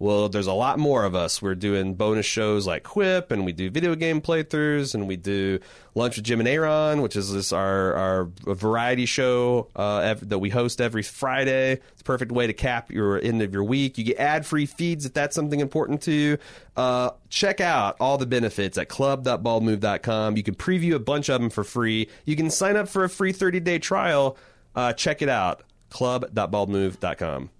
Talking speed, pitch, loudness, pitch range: 200 wpm, 120 Hz, -24 LUFS, 105-145 Hz